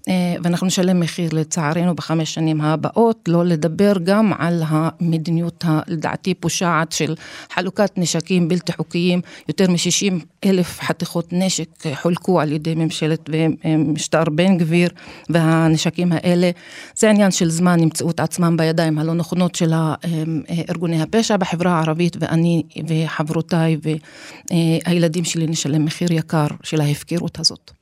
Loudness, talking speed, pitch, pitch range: -18 LUFS, 125 wpm, 170 Hz, 160-175 Hz